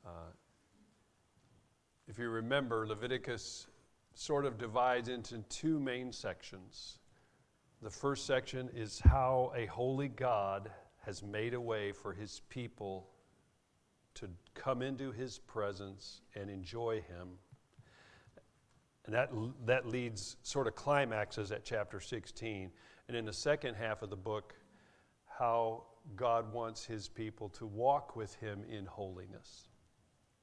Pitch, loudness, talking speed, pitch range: 115 Hz, -38 LUFS, 125 wpm, 105-125 Hz